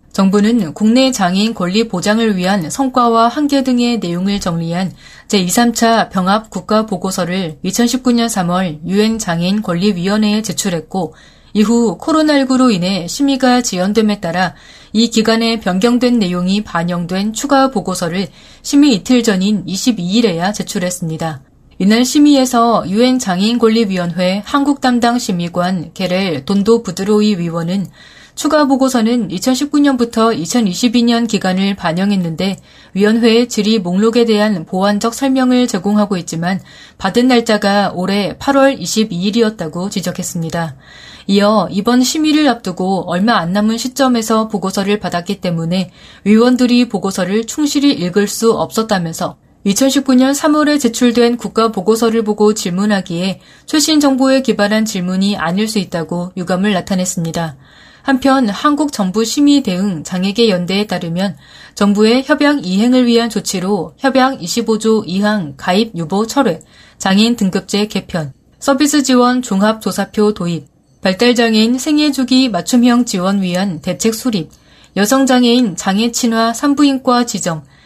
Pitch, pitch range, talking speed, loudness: 210 Hz, 185-240 Hz, 300 characters per minute, -14 LUFS